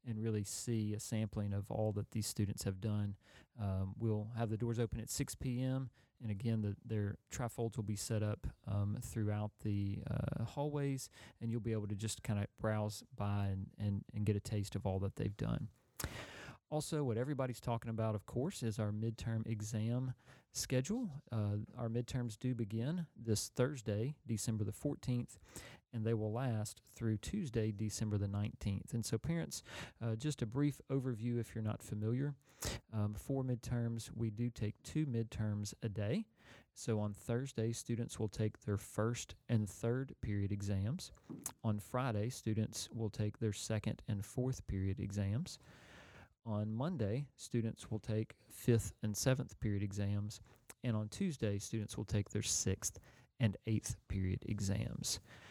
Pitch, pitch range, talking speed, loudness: 110 Hz, 105-120 Hz, 165 wpm, -40 LUFS